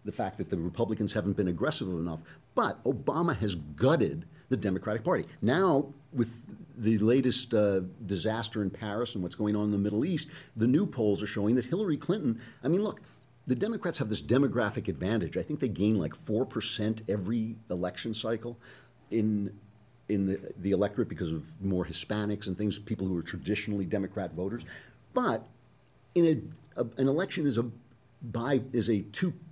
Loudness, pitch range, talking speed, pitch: -31 LUFS, 100-130 Hz, 180 wpm, 110 Hz